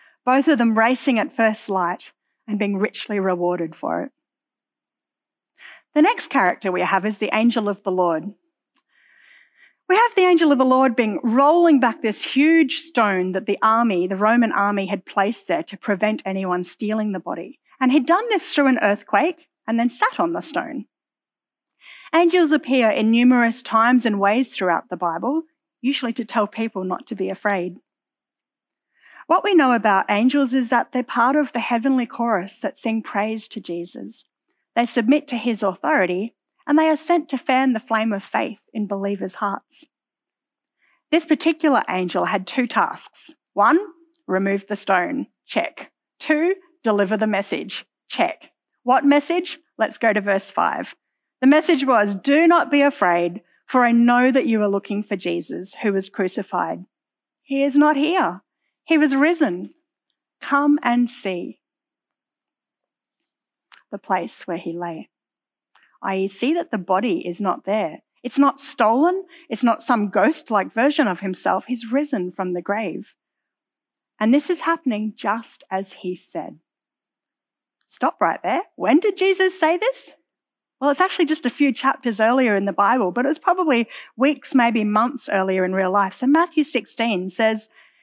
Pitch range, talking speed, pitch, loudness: 205-305 Hz, 165 wpm, 245 Hz, -20 LUFS